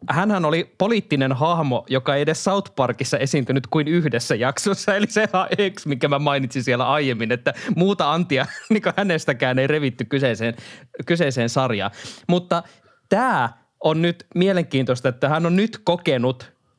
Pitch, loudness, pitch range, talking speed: 150 Hz, -21 LUFS, 130-175 Hz, 155 wpm